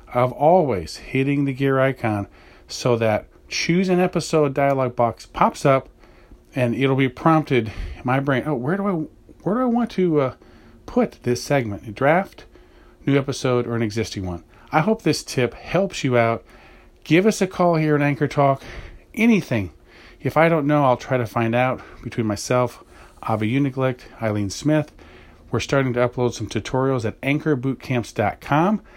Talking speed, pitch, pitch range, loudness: 170 wpm, 130 Hz, 115-150 Hz, -21 LUFS